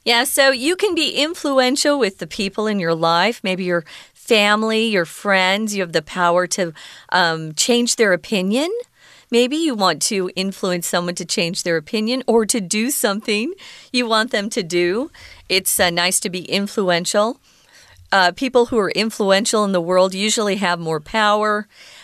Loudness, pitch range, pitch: -18 LUFS, 180-235 Hz, 210 Hz